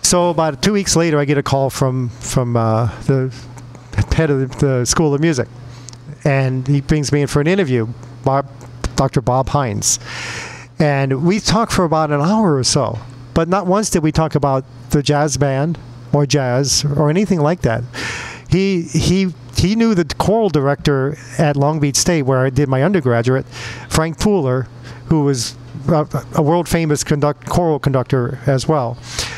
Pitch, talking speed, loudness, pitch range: 145 Hz, 175 wpm, -16 LUFS, 125-160 Hz